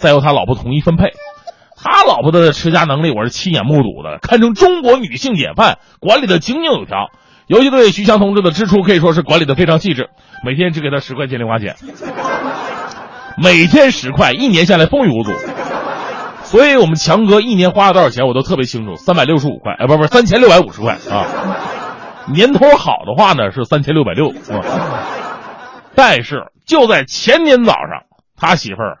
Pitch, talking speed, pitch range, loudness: 170 Hz, 295 characters per minute, 145-210 Hz, -11 LUFS